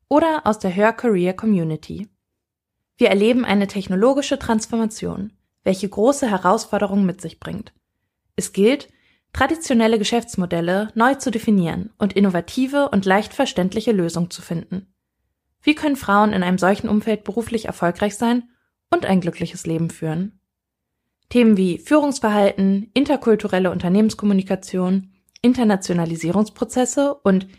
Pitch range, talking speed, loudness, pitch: 185-235 Hz, 115 wpm, -19 LUFS, 205 Hz